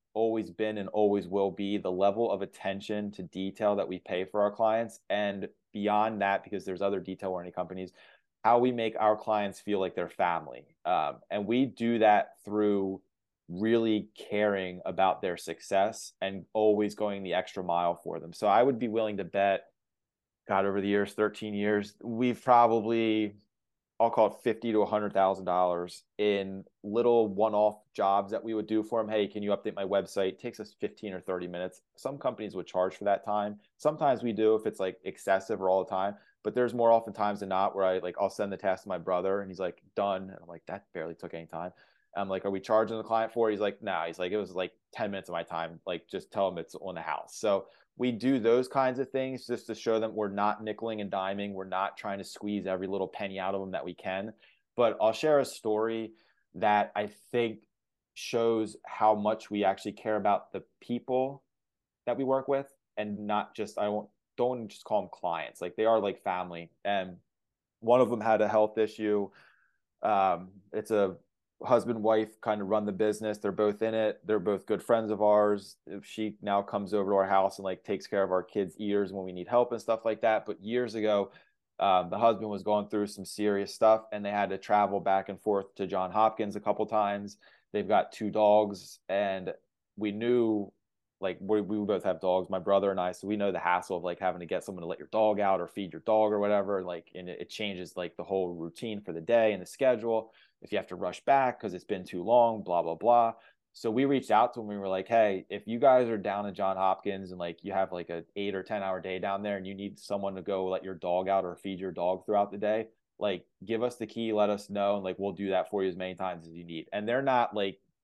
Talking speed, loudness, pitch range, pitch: 235 wpm, -30 LUFS, 95-110 Hz, 105 Hz